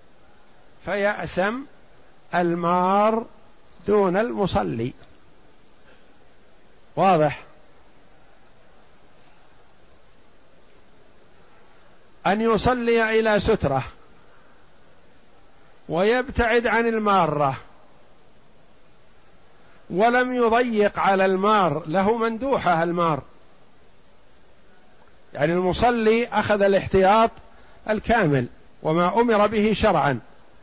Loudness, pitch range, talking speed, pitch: -21 LUFS, 175-225 Hz, 55 wpm, 205 Hz